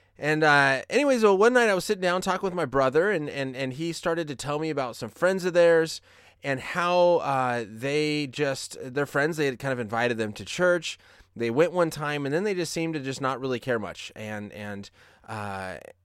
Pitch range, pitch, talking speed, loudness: 120-170 Hz, 140 Hz, 225 wpm, -25 LUFS